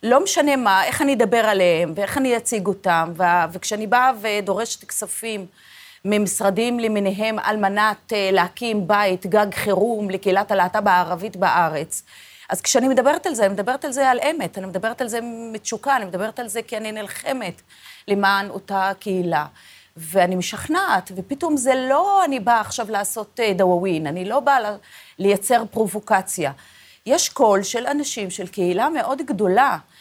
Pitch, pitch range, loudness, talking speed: 210 Hz, 190-240 Hz, -20 LUFS, 155 wpm